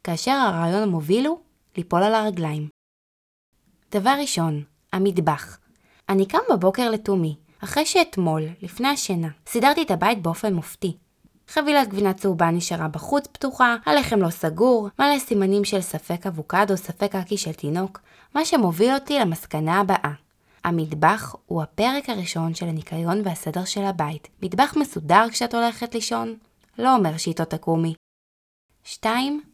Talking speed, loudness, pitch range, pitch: 135 wpm, -22 LUFS, 165-235 Hz, 195 Hz